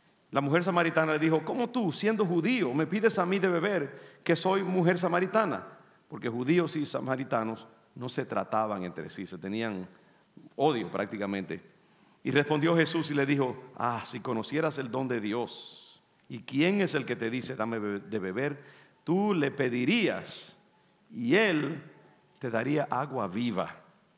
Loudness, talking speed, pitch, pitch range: -30 LUFS, 160 wpm, 145 Hz, 115-175 Hz